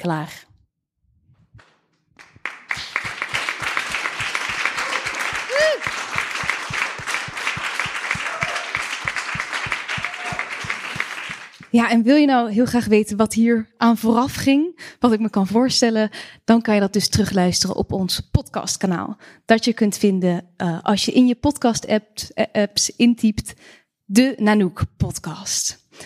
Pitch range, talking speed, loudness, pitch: 205-240 Hz, 100 wpm, -20 LUFS, 225 Hz